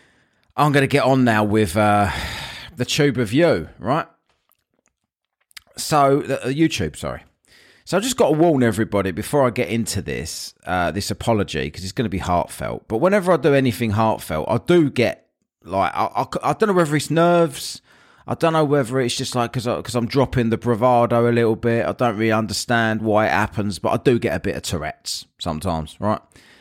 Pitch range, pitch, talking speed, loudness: 105-140 Hz, 120 Hz, 200 wpm, -20 LUFS